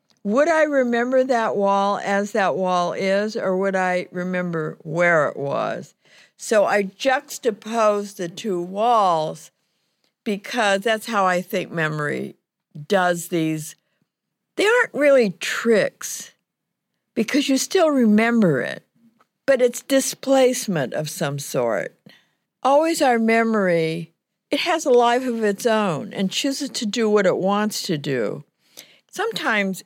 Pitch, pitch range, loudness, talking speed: 210 Hz, 185-250 Hz, -20 LUFS, 130 wpm